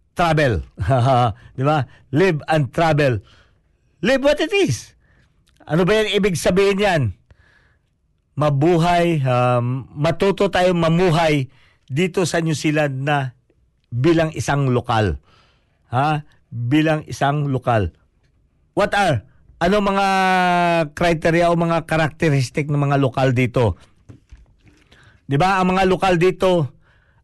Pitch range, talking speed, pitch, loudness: 125-175 Hz, 110 wpm, 150 Hz, -18 LUFS